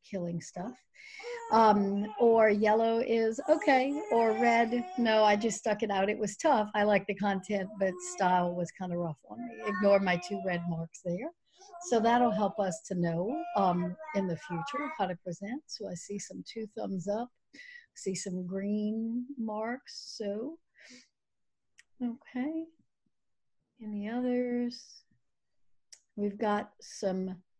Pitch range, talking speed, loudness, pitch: 190-245 Hz, 145 wpm, -31 LUFS, 215 Hz